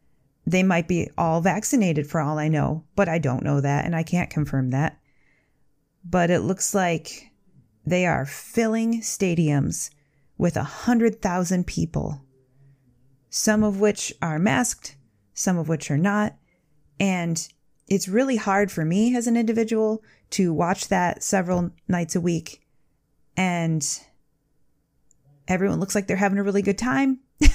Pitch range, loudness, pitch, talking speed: 150-200 Hz, -23 LUFS, 170 Hz, 150 wpm